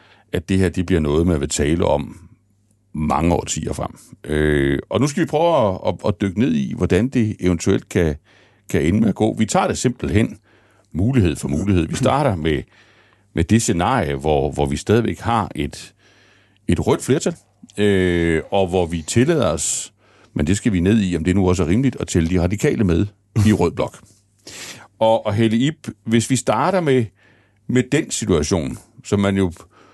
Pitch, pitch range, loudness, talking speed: 100 Hz, 90-110 Hz, -19 LUFS, 190 wpm